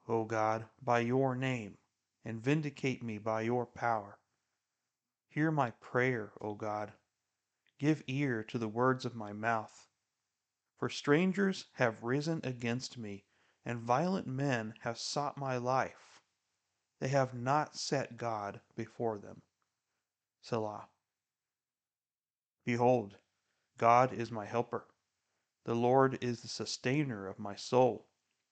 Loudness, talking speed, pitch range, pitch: -34 LUFS, 120 wpm, 110-130 Hz, 120 Hz